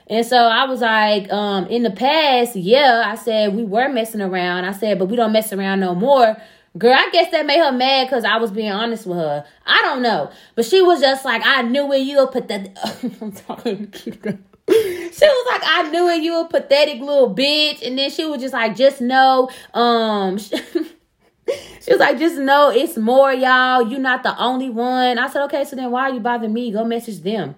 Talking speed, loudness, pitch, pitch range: 225 wpm, -16 LUFS, 245 Hz, 220-275 Hz